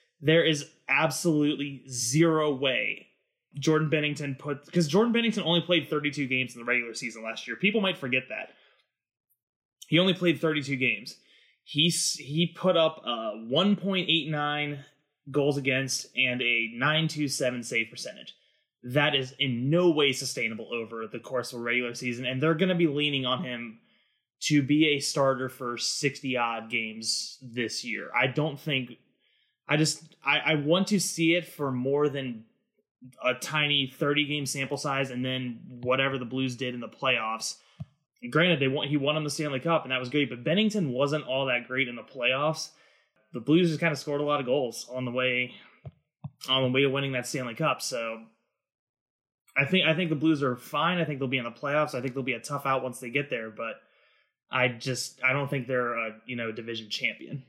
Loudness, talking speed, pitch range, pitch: -27 LUFS, 200 wpm, 125-155 Hz, 140 Hz